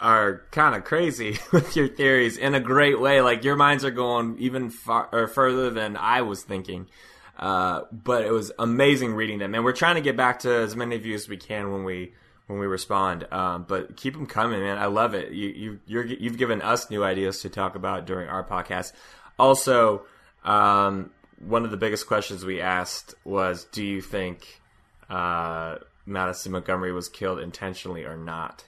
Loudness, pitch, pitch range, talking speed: -24 LUFS, 105 Hz, 95-125 Hz, 195 wpm